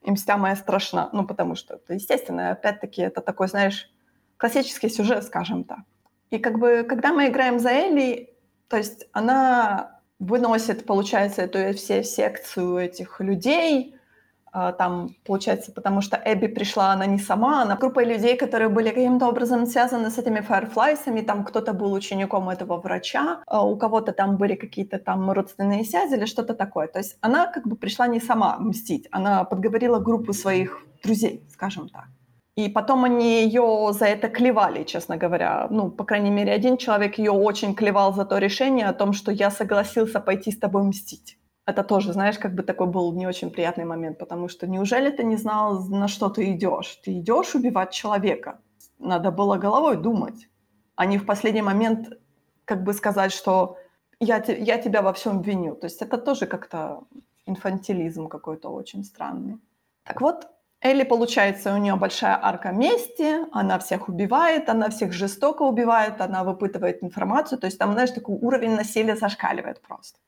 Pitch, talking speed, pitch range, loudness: 210 Hz, 170 wpm, 195-235 Hz, -23 LUFS